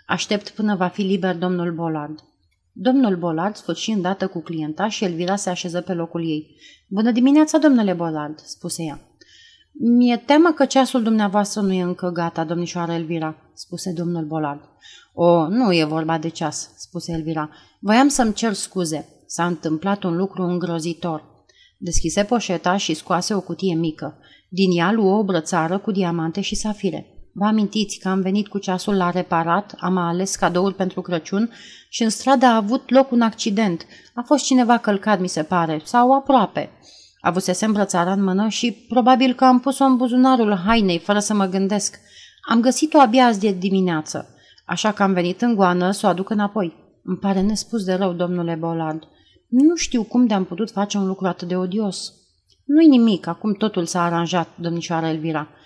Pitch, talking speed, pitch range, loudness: 190 Hz, 175 wpm, 170-220 Hz, -20 LUFS